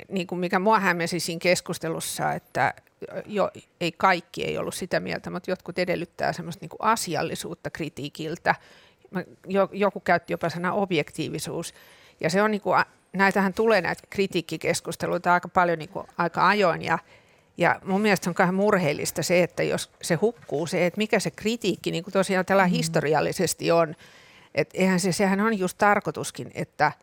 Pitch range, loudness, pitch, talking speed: 170-195 Hz, -25 LUFS, 180 Hz, 155 wpm